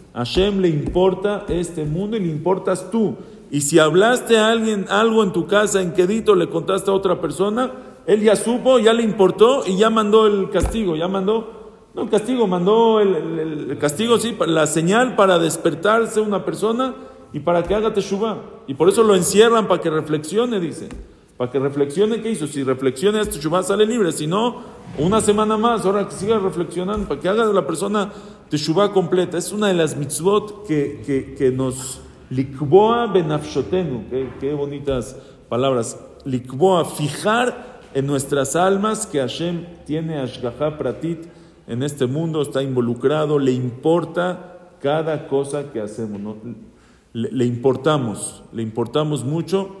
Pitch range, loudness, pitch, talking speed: 145-210 Hz, -19 LUFS, 180 Hz, 165 wpm